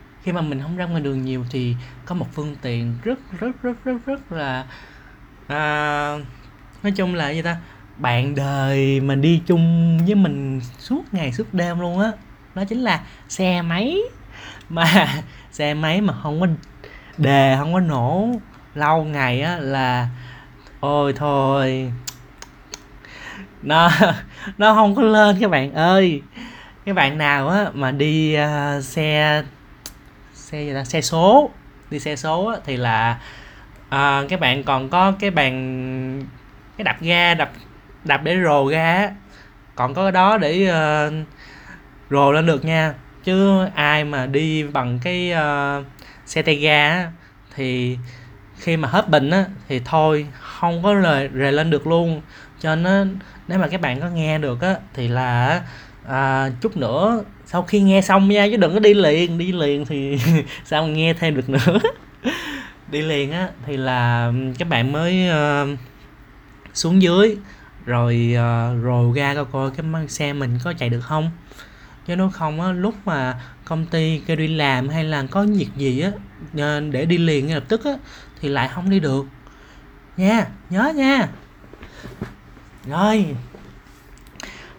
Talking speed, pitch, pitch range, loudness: 160 wpm, 150 Hz, 135-175 Hz, -19 LUFS